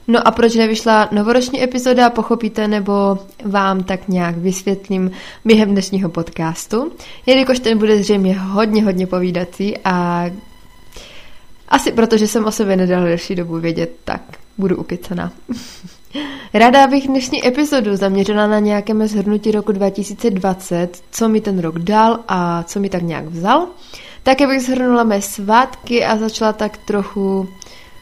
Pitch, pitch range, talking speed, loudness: 210 Hz, 190-230 Hz, 140 wpm, -16 LUFS